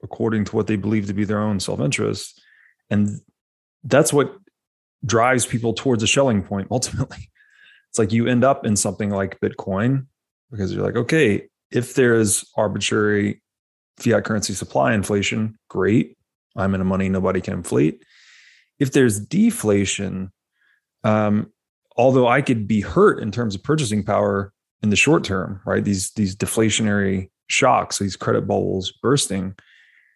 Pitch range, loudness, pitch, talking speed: 100-120 Hz, -20 LUFS, 105 Hz, 150 wpm